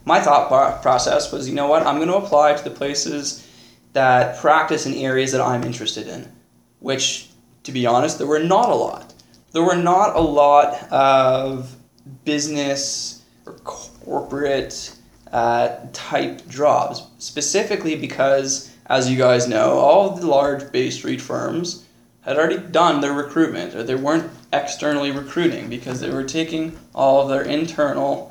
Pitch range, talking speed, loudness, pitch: 130-155 Hz, 155 wpm, -19 LUFS, 140 Hz